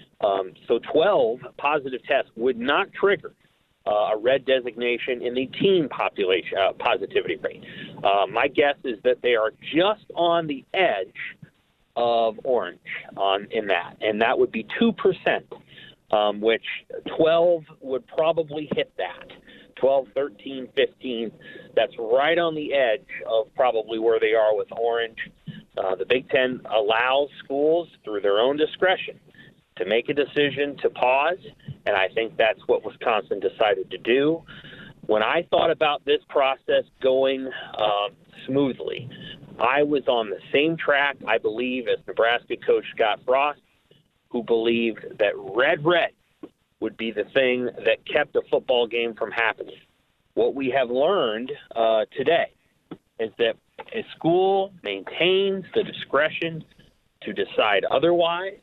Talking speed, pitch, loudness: 145 wpm, 150 Hz, -23 LUFS